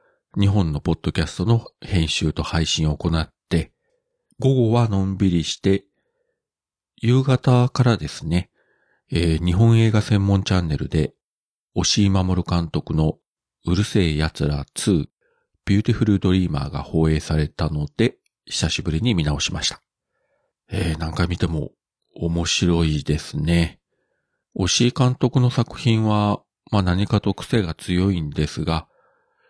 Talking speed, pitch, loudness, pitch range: 260 characters per minute, 90 Hz, -21 LUFS, 80-110 Hz